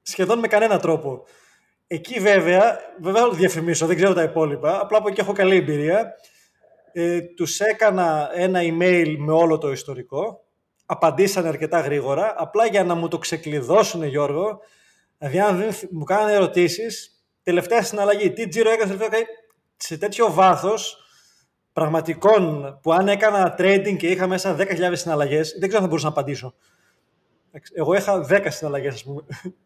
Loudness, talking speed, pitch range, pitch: -20 LUFS, 155 wpm, 160-205 Hz, 180 Hz